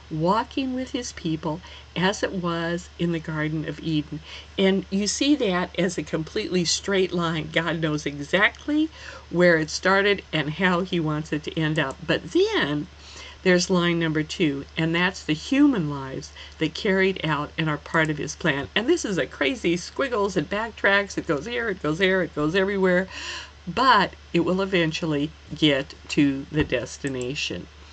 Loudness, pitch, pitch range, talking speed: -24 LUFS, 170 Hz, 155-190 Hz, 170 wpm